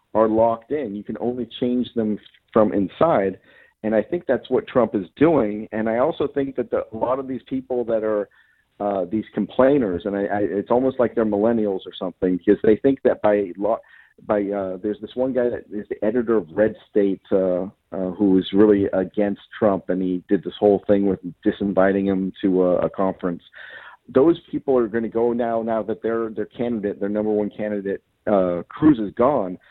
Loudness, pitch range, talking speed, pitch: -21 LUFS, 100-115 Hz, 205 wpm, 105 Hz